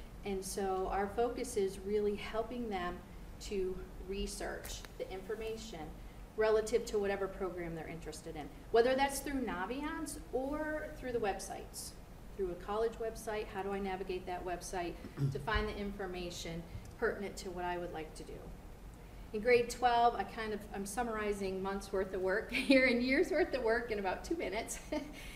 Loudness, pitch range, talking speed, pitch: -37 LUFS, 185-240 Hz, 170 wpm, 205 Hz